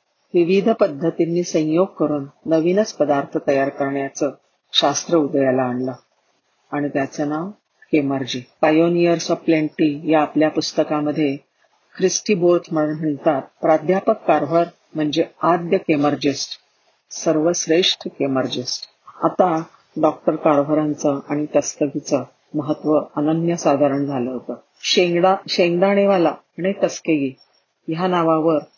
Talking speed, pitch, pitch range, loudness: 85 wpm, 155 Hz, 145-175 Hz, -19 LUFS